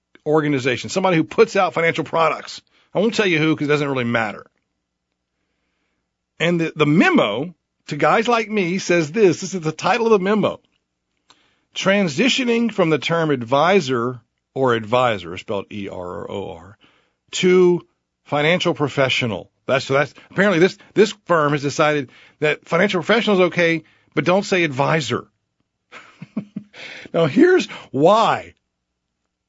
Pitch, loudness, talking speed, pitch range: 155 Hz, -18 LUFS, 135 wpm, 125-185 Hz